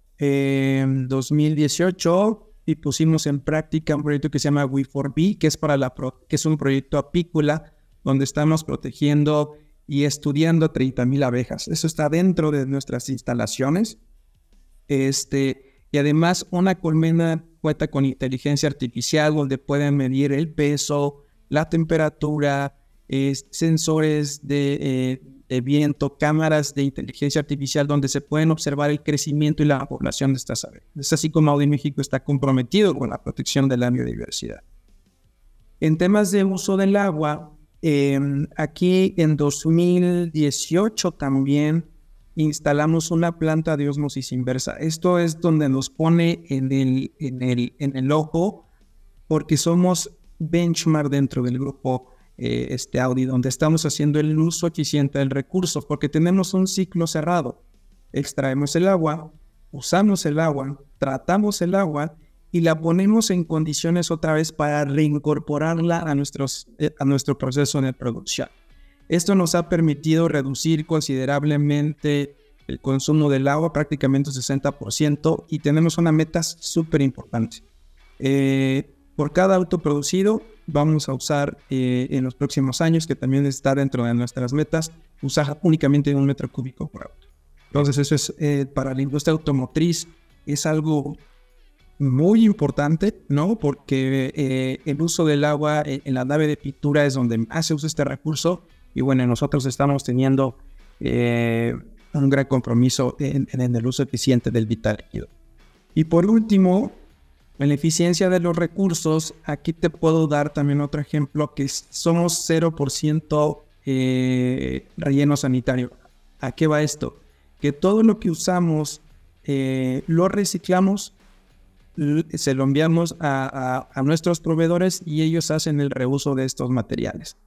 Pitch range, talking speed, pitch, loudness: 135-160 Hz, 145 wpm, 145 Hz, -21 LUFS